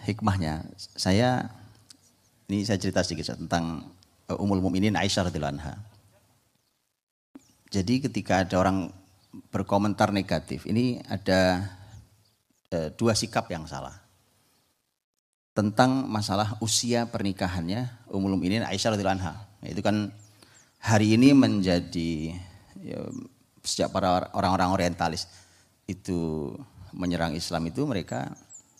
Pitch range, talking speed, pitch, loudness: 90-105 Hz, 95 wpm, 95 Hz, -27 LUFS